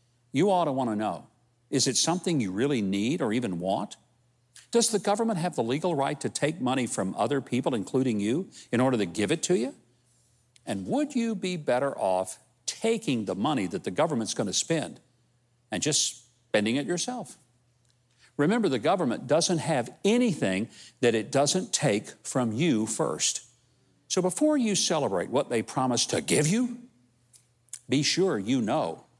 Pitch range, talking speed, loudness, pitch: 120-180 Hz, 175 wpm, -27 LUFS, 130 Hz